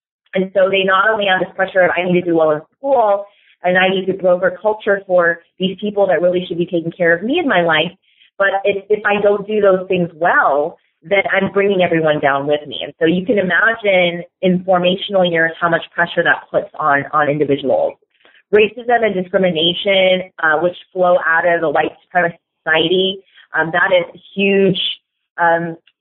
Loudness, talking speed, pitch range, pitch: -15 LUFS, 200 wpm, 170-195 Hz, 180 Hz